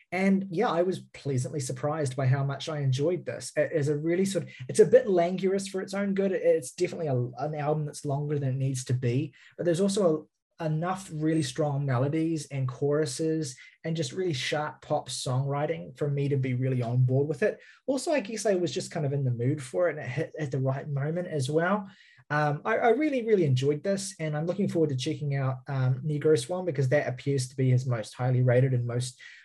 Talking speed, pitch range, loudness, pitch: 230 wpm, 135-175 Hz, -28 LUFS, 150 Hz